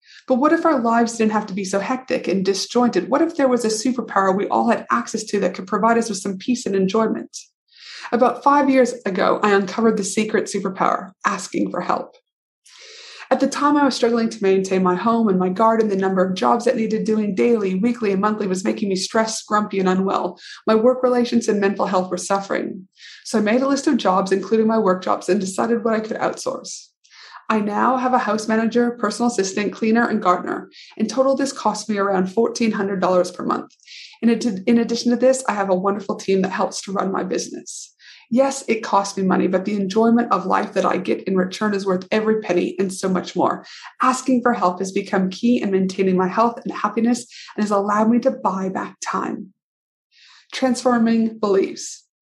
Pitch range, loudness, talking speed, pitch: 195-240 Hz, -20 LUFS, 210 wpm, 220 Hz